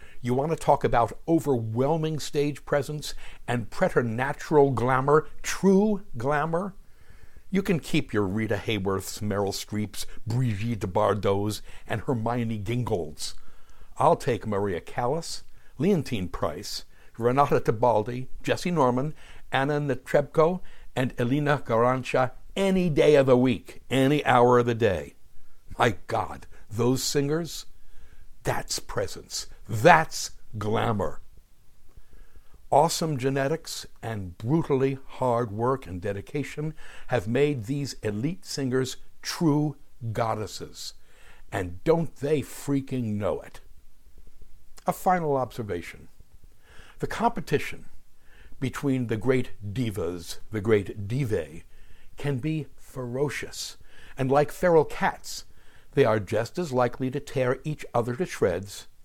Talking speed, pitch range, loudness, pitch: 110 wpm, 110-145 Hz, -26 LUFS, 125 Hz